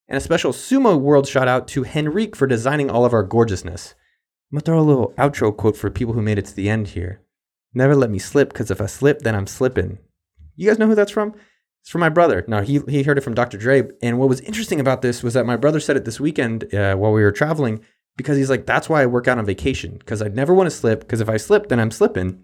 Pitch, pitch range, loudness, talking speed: 125 Hz, 110-145 Hz, -18 LUFS, 275 wpm